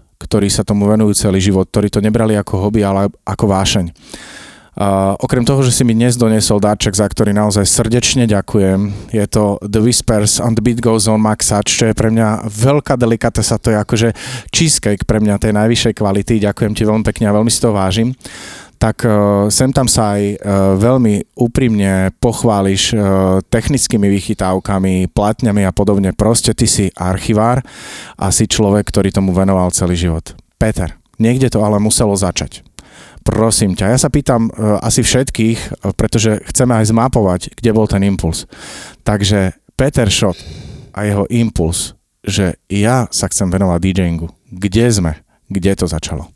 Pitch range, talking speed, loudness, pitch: 95-115 Hz, 165 wpm, -13 LUFS, 105 Hz